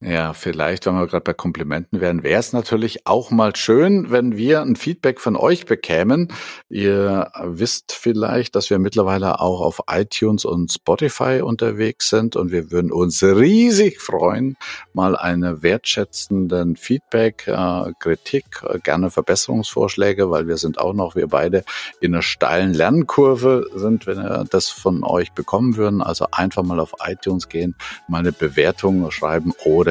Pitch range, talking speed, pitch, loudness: 85-115 Hz, 160 wpm, 95 Hz, -18 LUFS